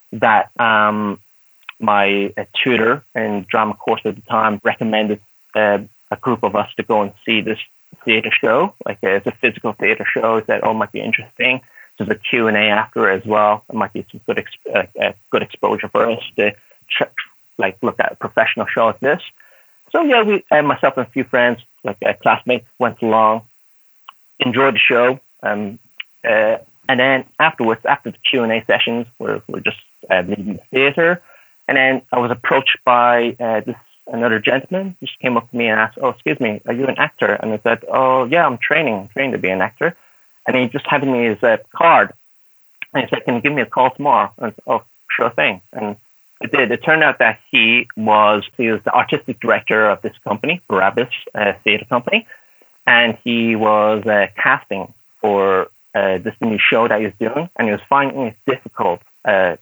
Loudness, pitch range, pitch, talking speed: -16 LUFS, 105-125 Hz, 115 Hz, 205 wpm